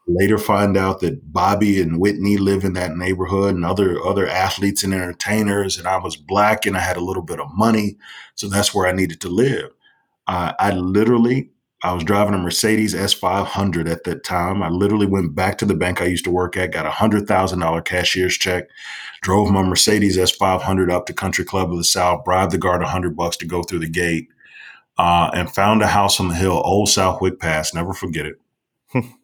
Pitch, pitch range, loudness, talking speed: 95 Hz, 90-100 Hz, -18 LUFS, 220 wpm